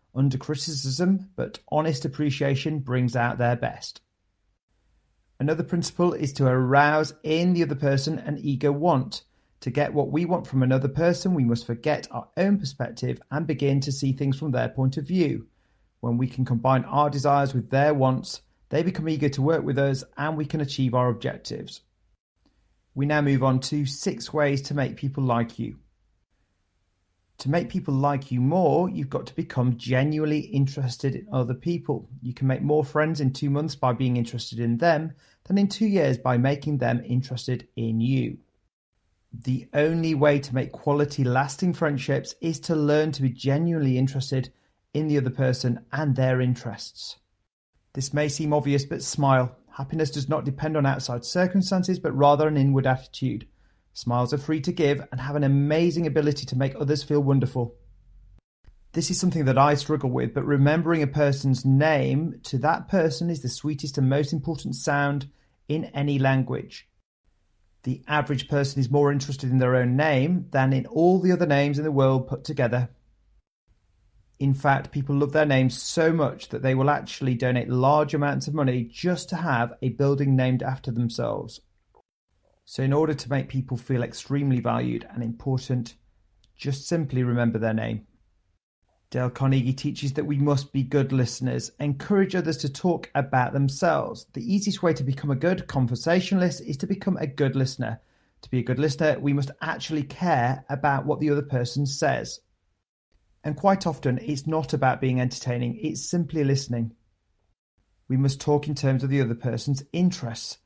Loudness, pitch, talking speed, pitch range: -25 LUFS, 140 Hz, 175 wpm, 125-150 Hz